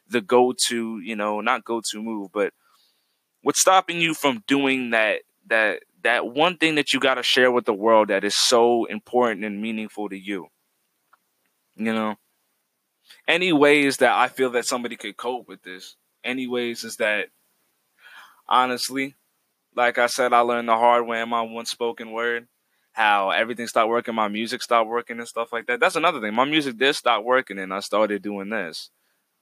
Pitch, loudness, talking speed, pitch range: 120 Hz, -22 LUFS, 180 wpm, 110-125 Hz